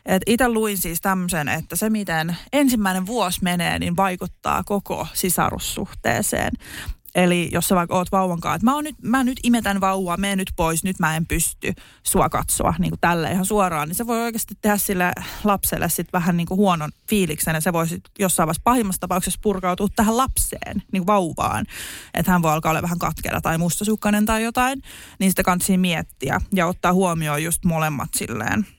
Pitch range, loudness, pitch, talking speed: 170-210 Hz, -21 LUFS, 185 Hz, 190 wpm